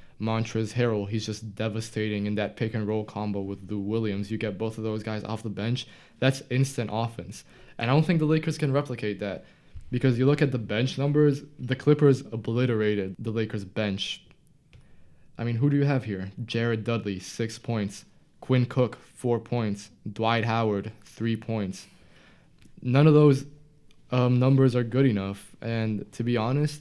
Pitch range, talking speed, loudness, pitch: 105-130 Hz, 175 wpm, -27 LUFS, 115 Hz